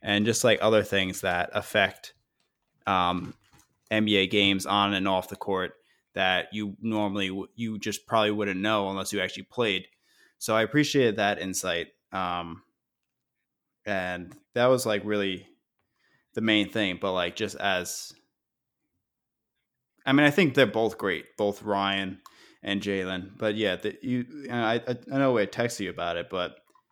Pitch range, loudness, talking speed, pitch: 95-115 Hz, -27 LUFS, 155 wpm, 105 Hz